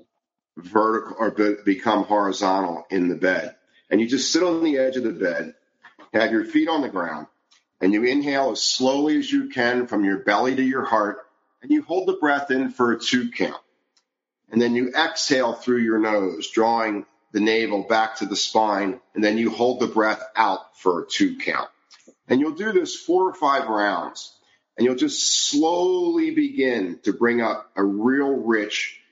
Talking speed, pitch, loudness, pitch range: 190 wpm, 120 Hz, -22 LUFS, 105-145 Hz